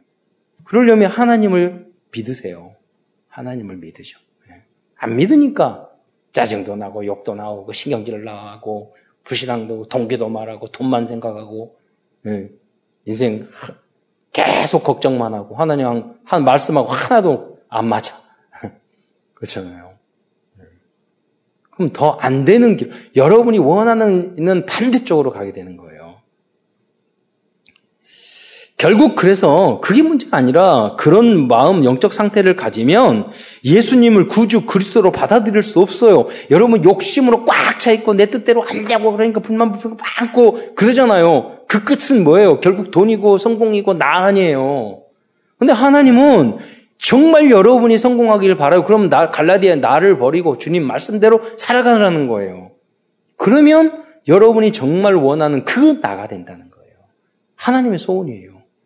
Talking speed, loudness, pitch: 290 characters per minute, -13 LUFS, 200 Hz